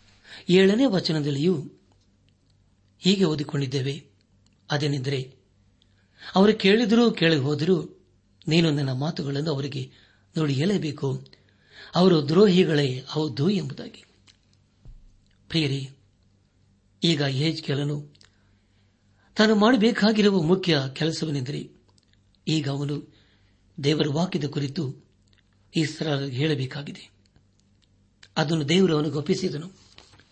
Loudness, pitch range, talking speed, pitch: -24 LUFS, 100-160 Hz, 75 wpm, 140 Hz